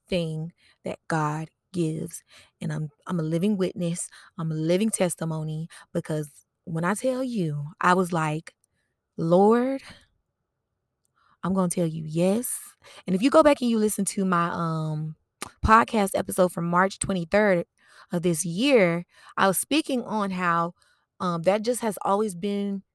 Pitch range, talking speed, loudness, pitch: 165-205 Hz, 150 wpm, -25 LUFS, 180 Hz